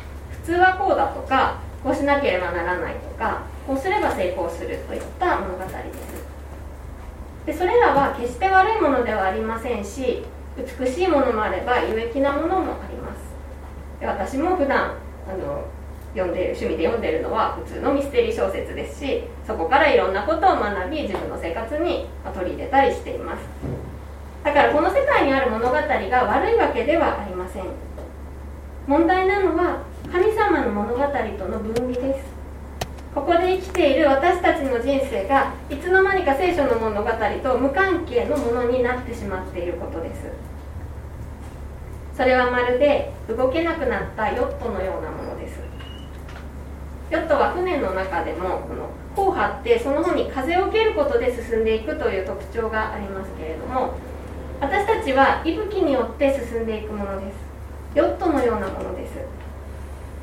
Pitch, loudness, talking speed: 250 Hz, -22 LUFS, 330 characters per minute